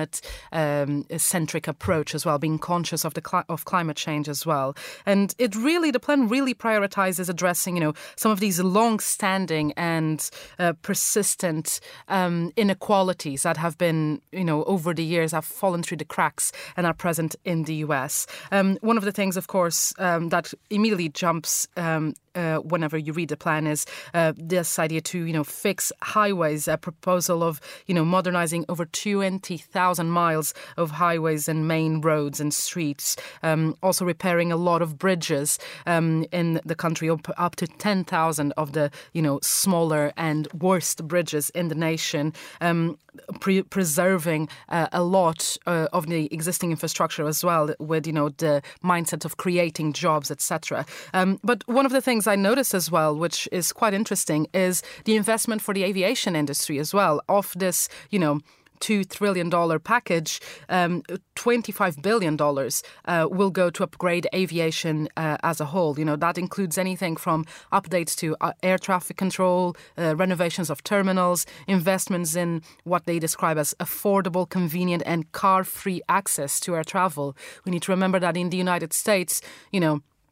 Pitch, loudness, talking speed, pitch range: 170 Hz, -24 LUFS, 175 wpm, 160-185 Hz